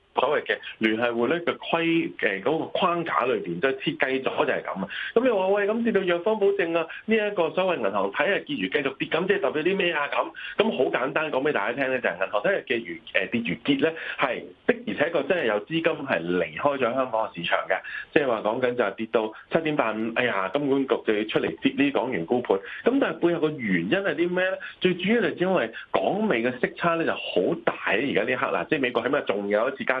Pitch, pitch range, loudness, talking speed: 165 Hz, 120-185 Hz, -25 LUFS, 360 characters per minute